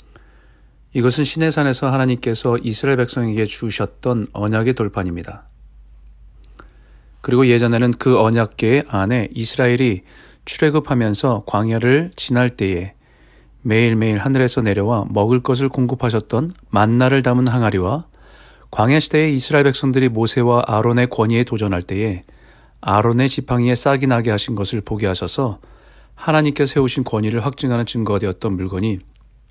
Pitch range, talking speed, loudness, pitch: 105-130 Hz, 330 characters per minute, -17 LUFS, 120 Hz